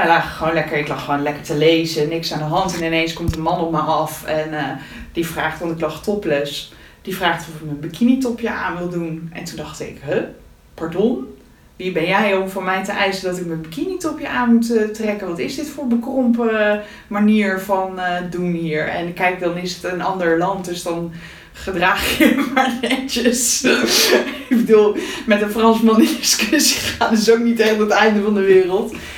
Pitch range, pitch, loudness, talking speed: 165-225 Hz, 190 Hz, -18 LUFS, 215 wpm